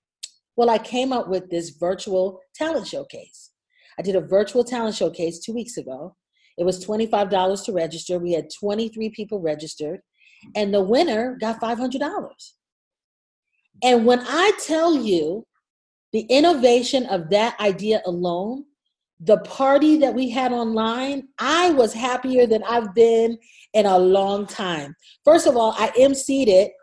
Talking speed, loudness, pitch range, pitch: 150 wpm, -20 LUFS, 190-255 Hz, 225 Hz